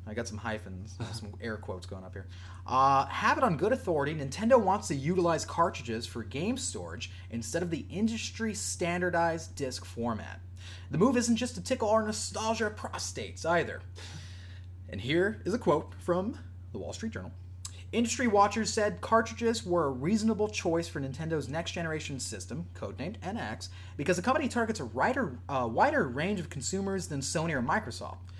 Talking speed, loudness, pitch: 170 wpm, -31 LUFS, 115 Hz